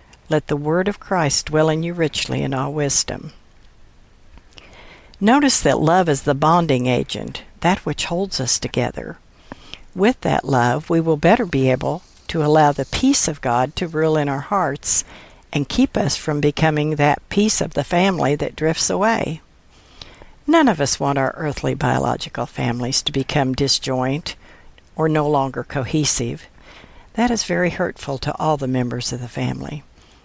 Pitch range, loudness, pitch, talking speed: 130-170 Hz, -19 LUFS, 150 Hz, 165 wpm